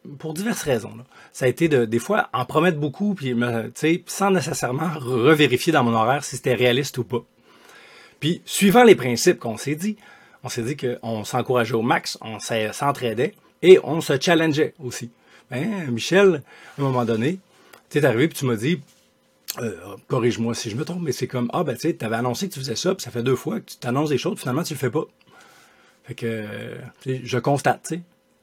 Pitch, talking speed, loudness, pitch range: 130 Hz, 215 wpm, -22 LUFS, 120-165 Hz